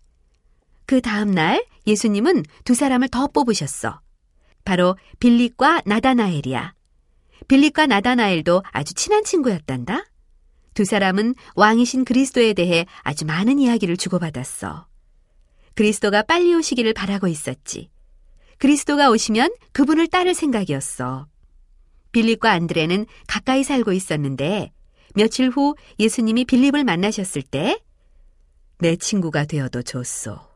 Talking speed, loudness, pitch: 290 characters per minute, -19 LUFS, 205 Hz